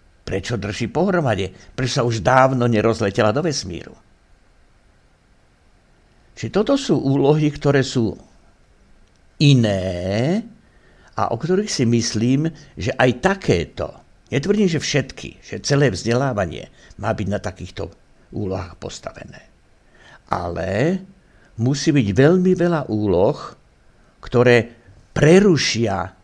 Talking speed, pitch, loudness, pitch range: 105 wpm, 120 Hz, -19 LUFS, 105-150 Hz